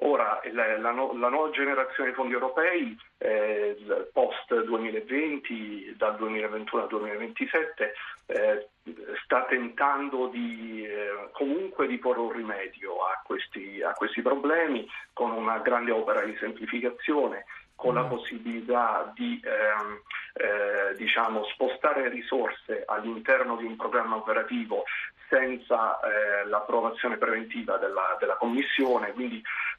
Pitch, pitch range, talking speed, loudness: 125 Hz, 110-140 Hz, 120 wpm, -28 LUFS